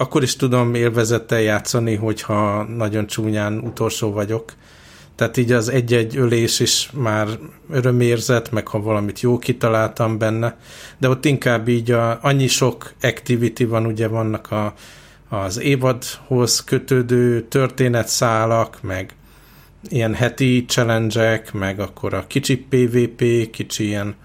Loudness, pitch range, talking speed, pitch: -19 LUFS, 110-125 Hz, 125 wpm, 115 Hz